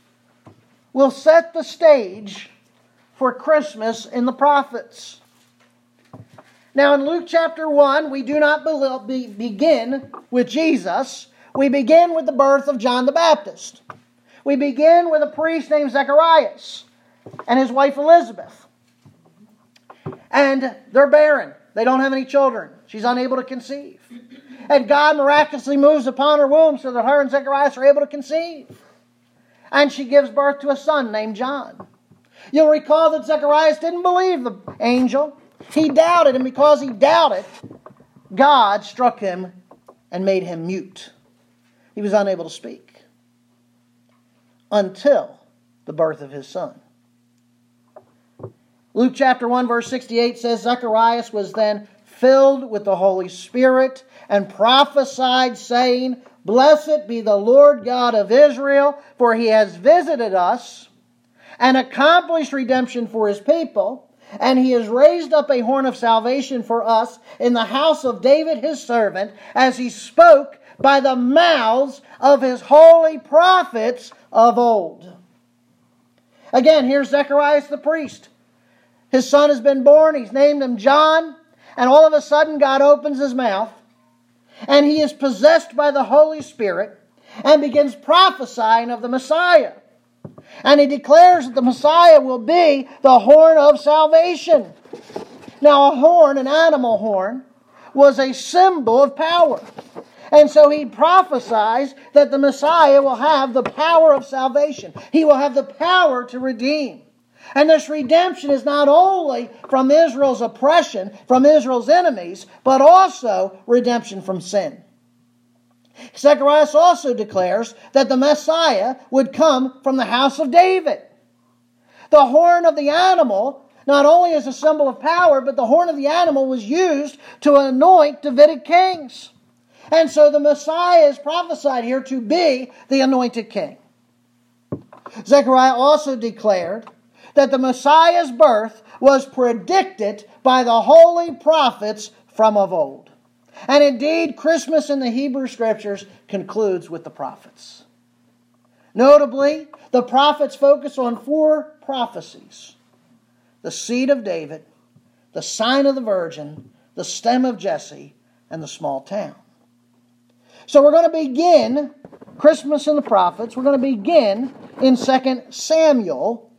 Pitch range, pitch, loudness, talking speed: 225-300 Hz, 270 Hz, -15 LUFS, 140 wpm